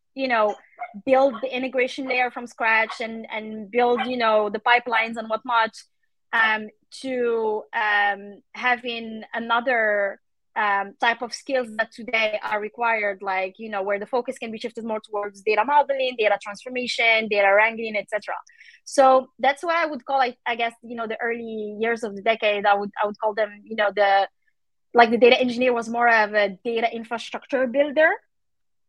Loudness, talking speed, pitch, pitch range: -22 LUFS, 175 wpm, 230 Hz, 215-250 Hz